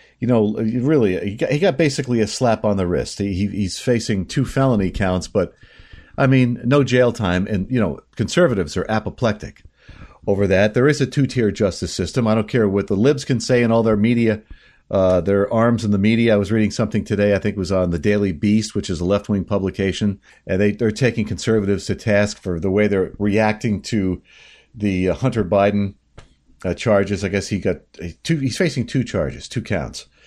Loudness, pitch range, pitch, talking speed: -19 LUFS, 100-115 Hz, 105 Hz, 210 wpm